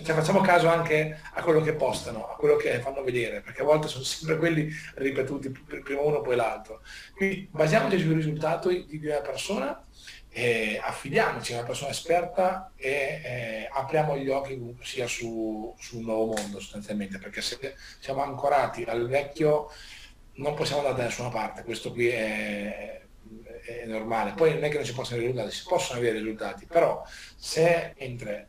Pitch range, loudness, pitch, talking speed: 115-155 Hz, -28 LUFS, 135 Hz, 175 wpm